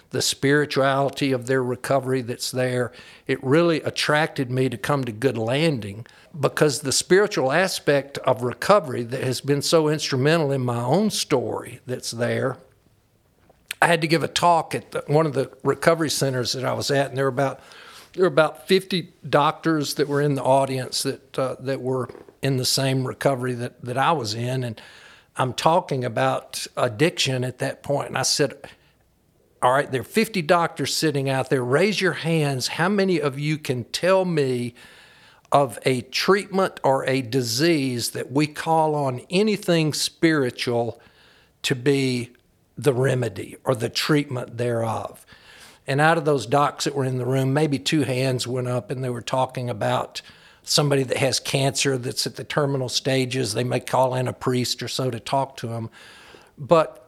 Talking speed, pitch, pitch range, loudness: 180 wpm, 135 Hz, 125-150 Hz, -22 LUFS